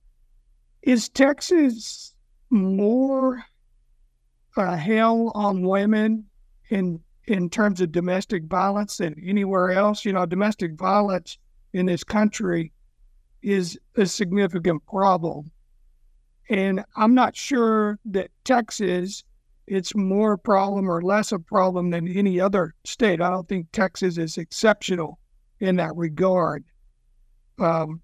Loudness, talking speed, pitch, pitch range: -23 LUFS, 120 wpm, 190 Hz, 175-210 Hz